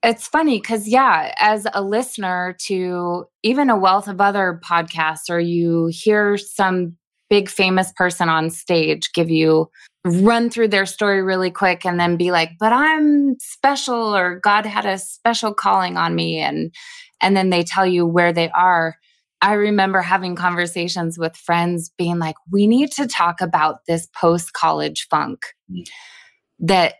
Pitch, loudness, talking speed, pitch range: 185 Hz, -18 LUFS, 160 wpm, 170-210 Hz